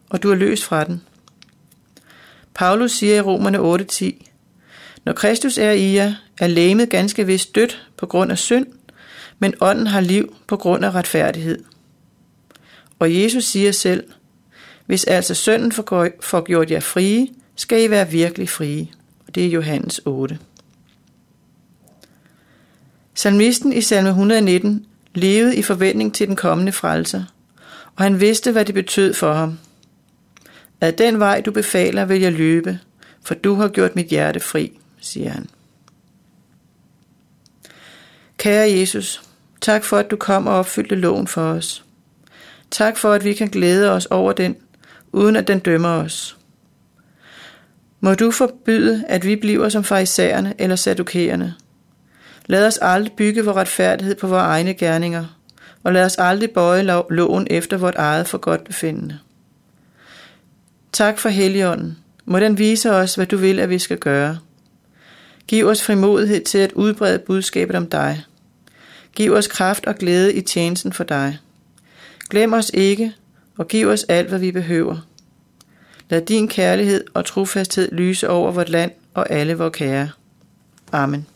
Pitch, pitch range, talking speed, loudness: 190 Hz, 170-210 Hz, 150 wpm, -17 LUFS